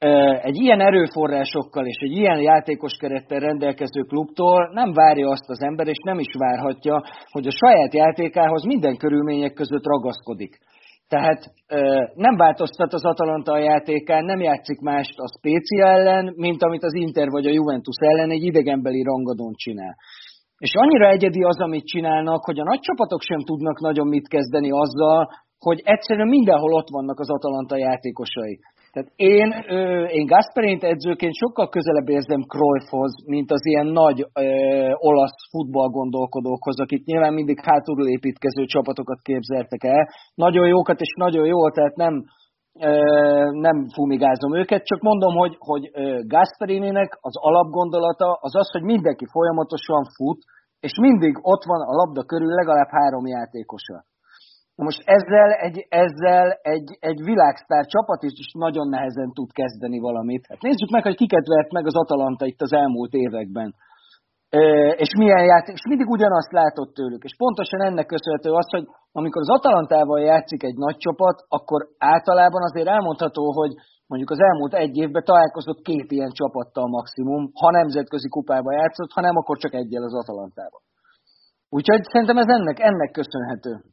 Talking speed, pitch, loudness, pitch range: 155 wpm, 155 Hz, -19 LUFS, 140-175 Hz